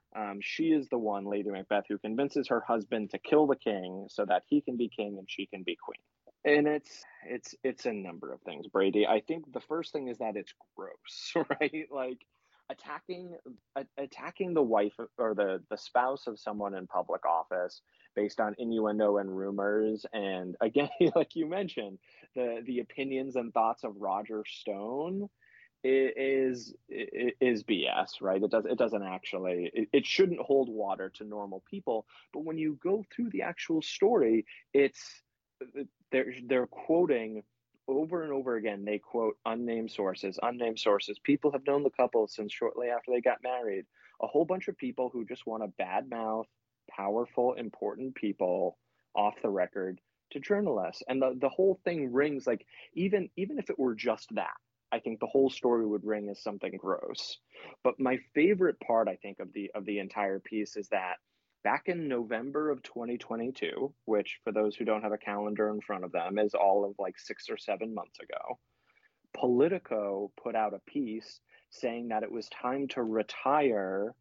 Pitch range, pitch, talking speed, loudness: 105-145 Hz, 120 Hz, 180 wpm, -32 LUFS